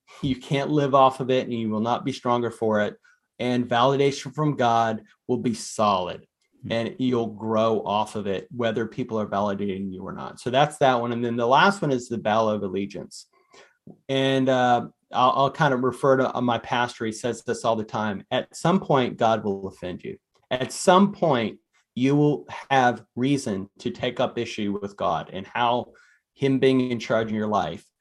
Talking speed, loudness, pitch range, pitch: 200 wpm, -24 LUFS, 110-135 Hz, 120 Hz